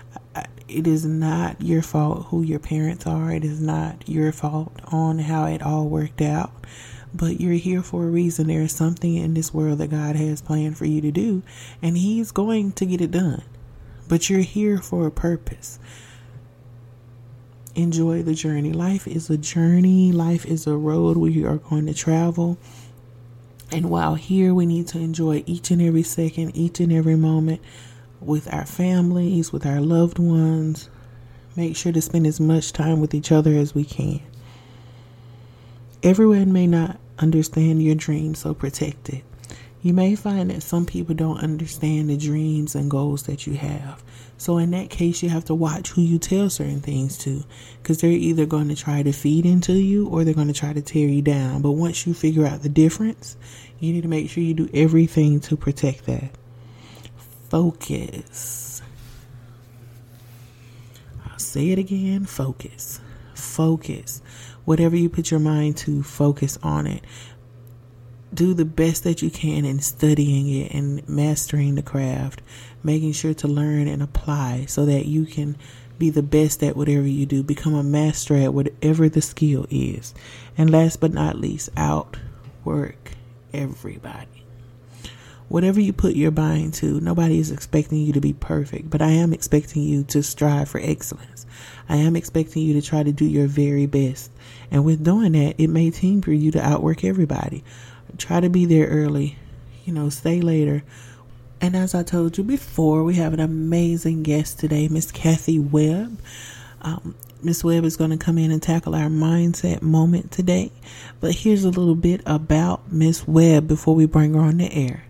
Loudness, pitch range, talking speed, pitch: -21 LUFS, 130-165 Hz, 180 wpm, 155 Hz